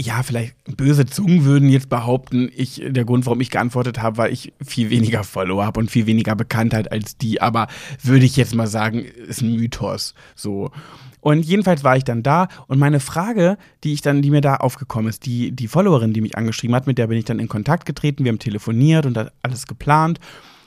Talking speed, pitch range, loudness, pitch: 215 wpm, 115-145 Hz, -18 LUFS, 125 Hz